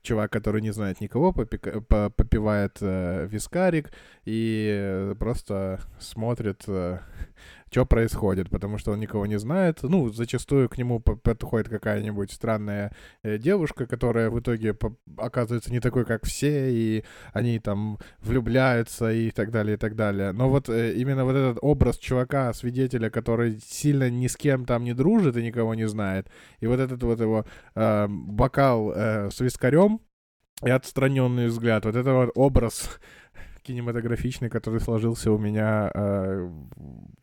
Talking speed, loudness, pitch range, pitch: 150 wpm, -25 LUFS, 105-125 Hz, 115 Hz